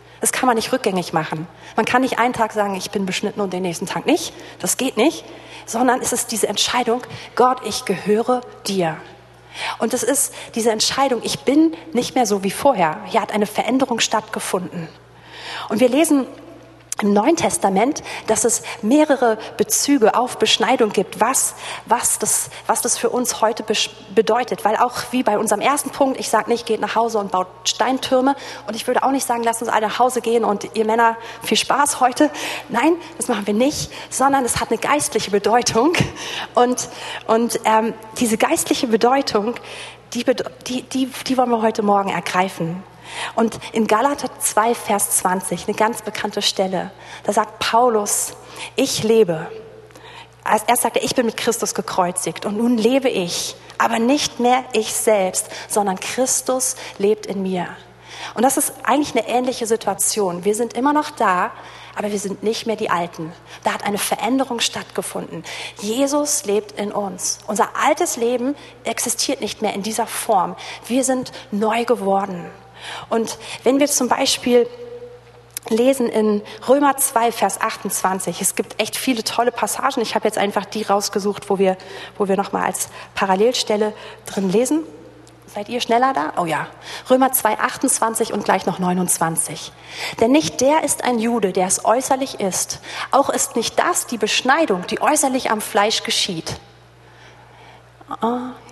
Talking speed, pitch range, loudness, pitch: 170 wpm, 205-250 Hz, -19 LUFS, 225 Hz